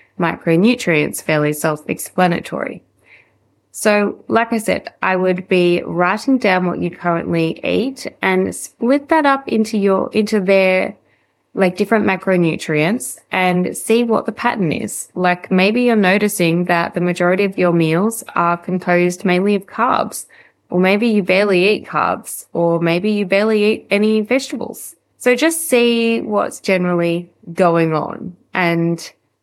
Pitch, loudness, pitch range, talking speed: 185 Hz, -16 LUFS, 175-220 Hz, 145 wpm